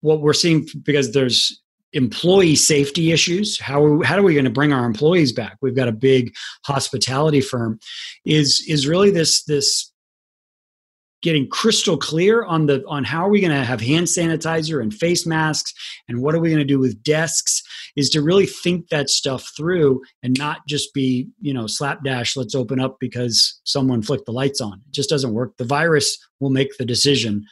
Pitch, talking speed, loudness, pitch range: 145 Hz, 190 wpm, -18 LUFS, 130-160 Hz